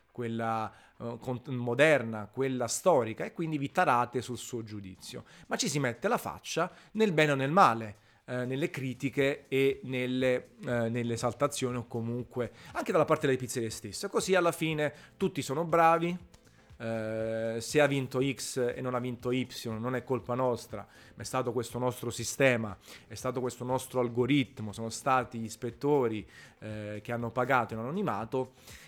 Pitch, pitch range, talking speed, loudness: 125 Hz, 115-135 Hz, 165 wpm, -31 LUFS